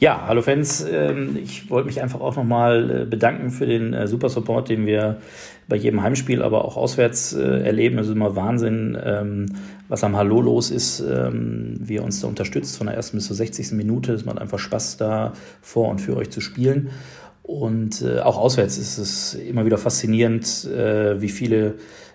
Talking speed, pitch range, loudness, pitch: 175 wpm, 100-115 Hz, -21 LUFS, 110 Hz